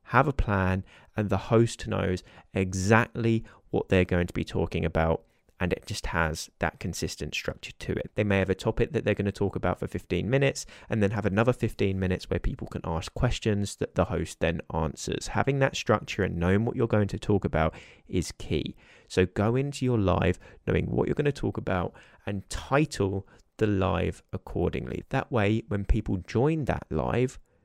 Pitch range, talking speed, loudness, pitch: 90-115 Hz, 200 wpm, -28 LUFS, 100 Hz